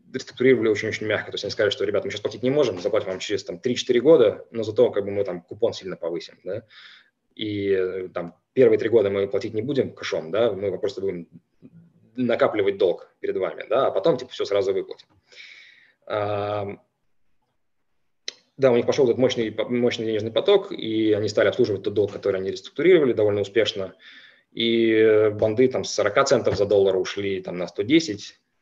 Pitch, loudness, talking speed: 335 Hz, -22 LUFS, 185 wpm